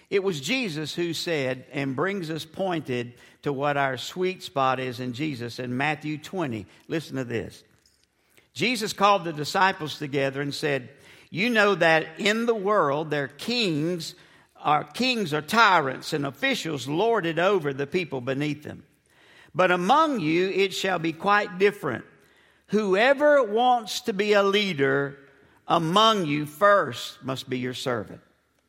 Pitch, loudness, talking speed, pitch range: 165 Hz, -24 LUFS, 155 wpm, 140-200 Hz